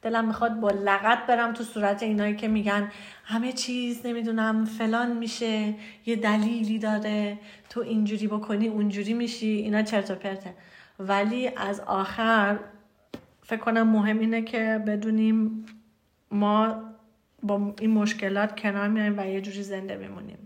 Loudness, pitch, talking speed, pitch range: -26 LUFS, 215 Hz, 140 wpm, 205-225 Hz